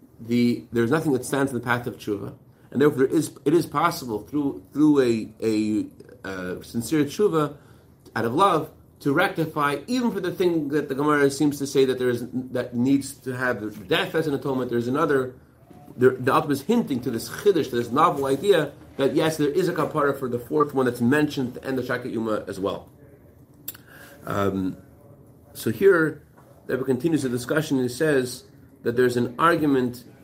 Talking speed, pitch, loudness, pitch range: 195 wpm, 135 Hz, -24 LUFS, 120-150 Hz